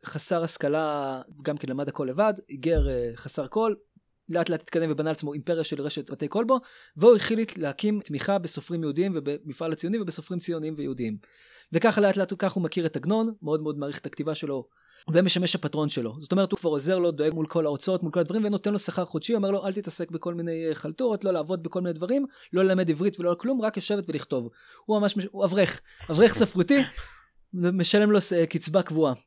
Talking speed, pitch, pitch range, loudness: 170 wpm, 170 Hz, 150-195 Hz, -26 LUFS